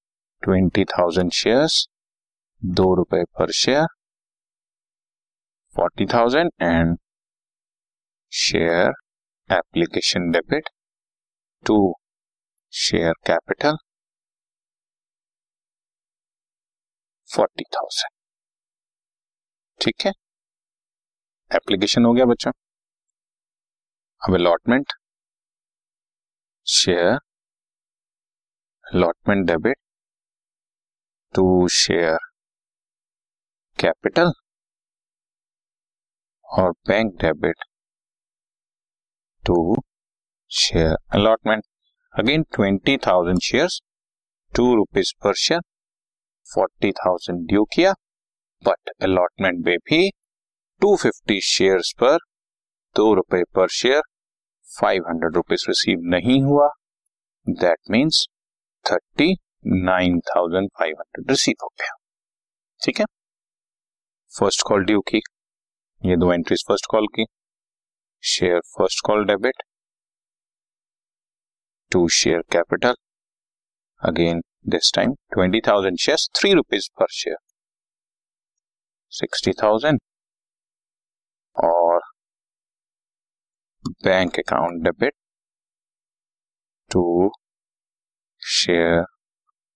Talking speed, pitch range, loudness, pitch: 70 wpm, 85-115 Hz, -20 LUFS, 95 Hz